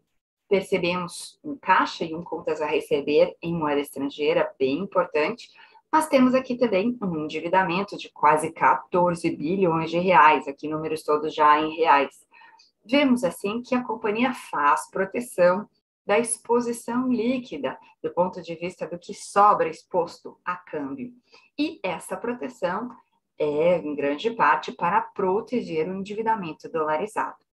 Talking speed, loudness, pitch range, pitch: 135 wpm, -24 LUFS, 165-245 Hz, 195 Hz